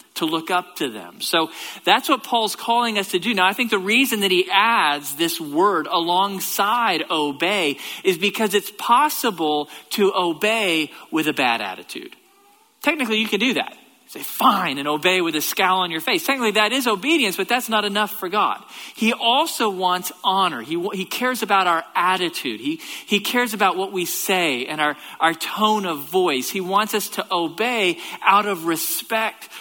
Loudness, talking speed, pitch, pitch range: -20 LUFS, 185 wpm, 200 Hz, 180-235 Hz